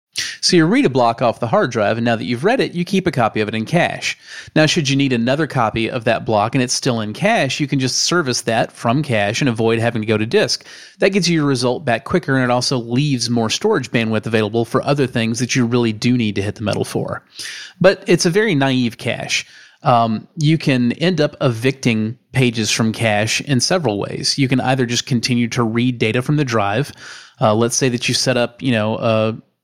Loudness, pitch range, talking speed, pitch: -17 LUFS, 115-140 Hz, 240 wpm, 125 Hz